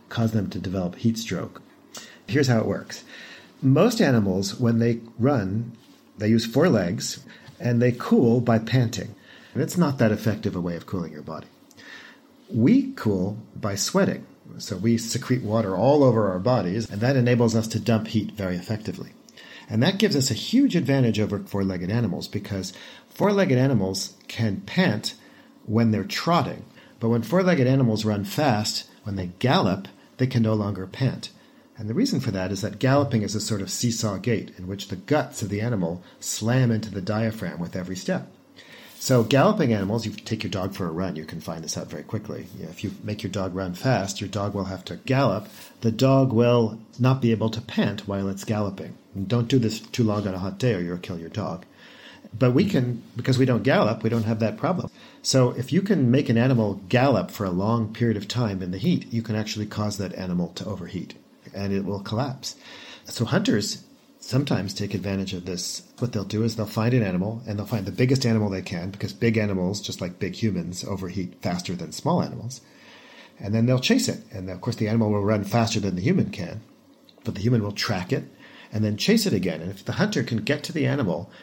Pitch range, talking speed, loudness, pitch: 100-120 Hz, 210 wpm, -24 LUFS, 110 Hz